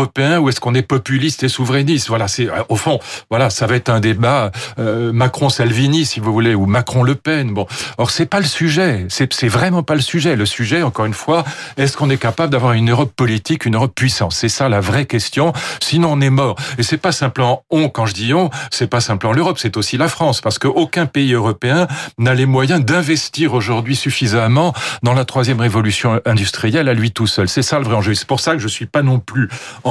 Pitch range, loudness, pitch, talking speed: 115-145 Hz, -15 LUFS, 130 Hz, 230 wpm